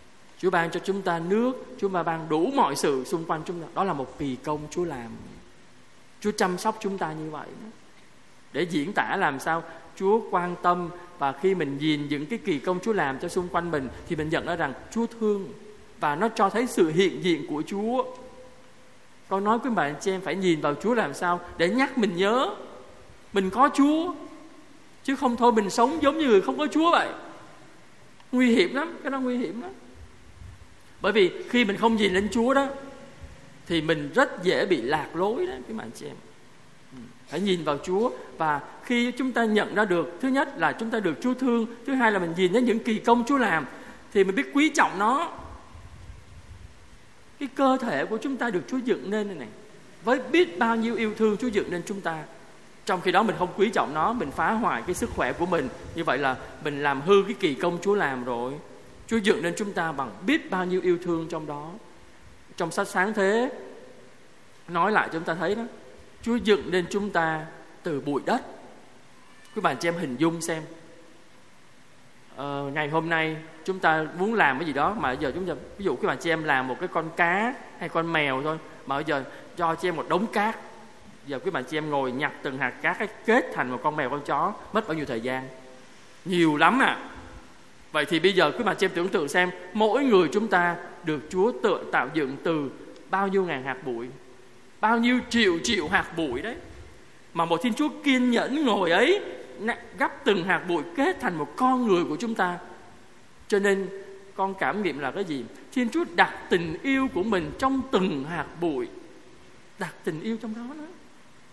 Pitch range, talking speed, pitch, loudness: 165-235 Hz, 215 wpm, 190 Hz, -26 LUFS